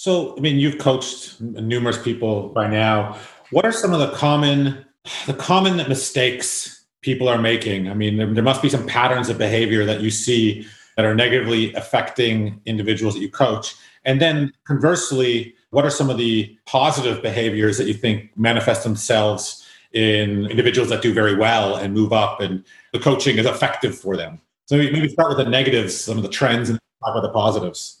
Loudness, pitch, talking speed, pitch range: -19 LUFS, 115 Hz, 190 wpm, 110-135 Hz